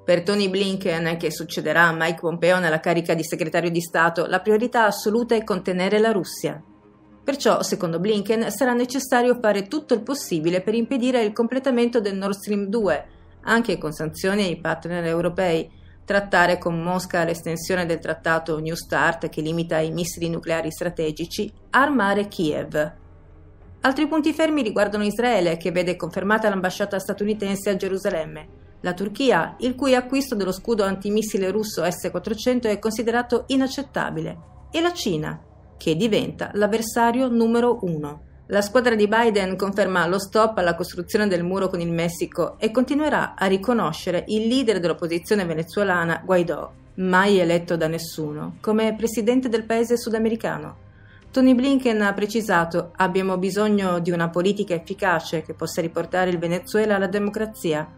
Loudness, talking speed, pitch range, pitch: -22 LUFS, 145 wpm, 170-220 Hz, 195 Hz